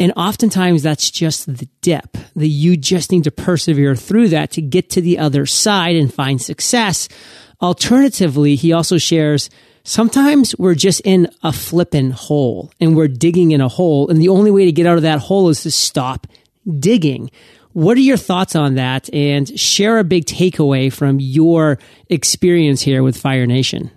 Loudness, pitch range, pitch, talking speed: -14 LUFS, 145-180 Hz, 165 Hz, 180 wpm